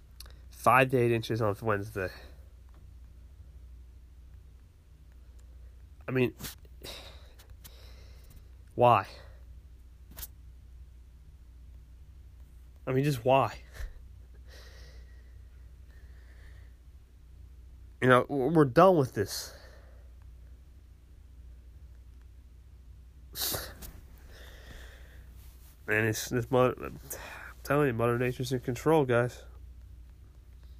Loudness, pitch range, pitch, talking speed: -28 LUFS, 75-90 Hz, 75 Hz, 60 wpm